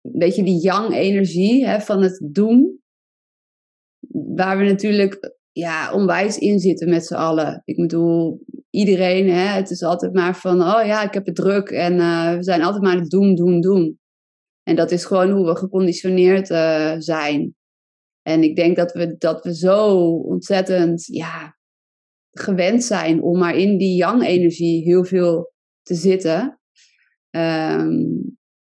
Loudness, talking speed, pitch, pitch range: -18 LUFS, 155 wpm, 180 Hz, 170-195 Hz